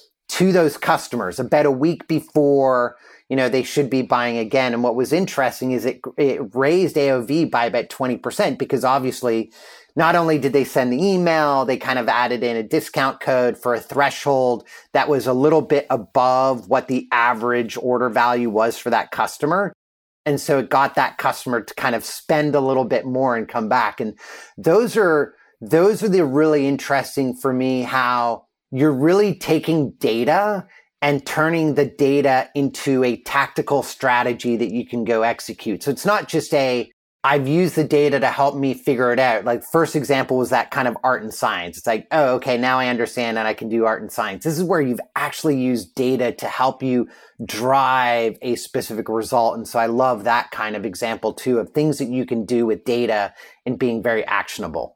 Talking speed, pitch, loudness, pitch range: 200 wpm, 130 Hz, -19 LUFS, 120-145 Hz